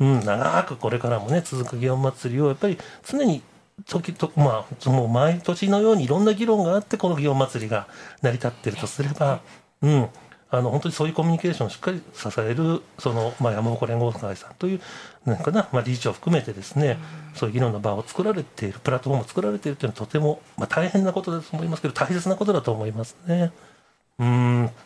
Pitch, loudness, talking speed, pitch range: 145 Hz, -24 LUFS, 455 characters per minute, 120-170 Hz